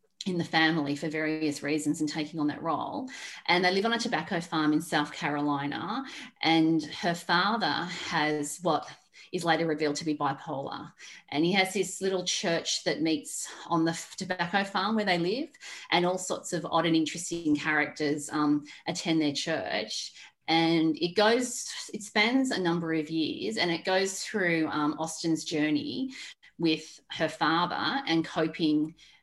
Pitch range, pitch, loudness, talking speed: 155-190 Hz, 165 Hz, -29 LUFS, 165 wpm